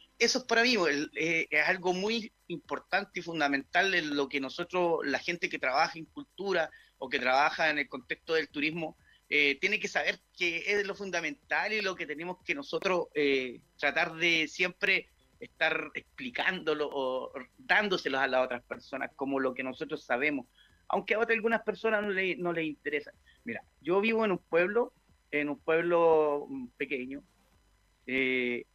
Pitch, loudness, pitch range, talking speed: 160 Hz, -30 LUFS, 140-185 Hz, 170 wpm